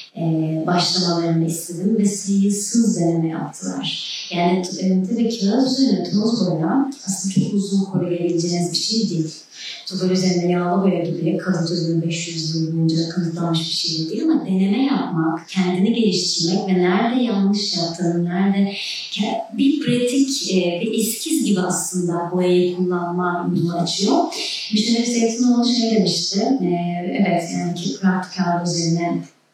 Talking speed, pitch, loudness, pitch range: 145 wpm, 180 Hz, -20 LUFS, 170-215 Hz